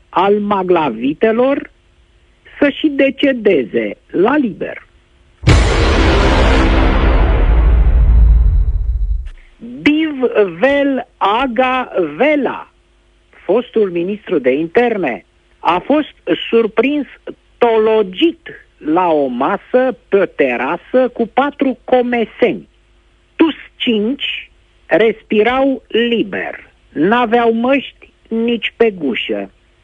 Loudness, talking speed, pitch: -14 LUFS, 70 wpm, 225 Hz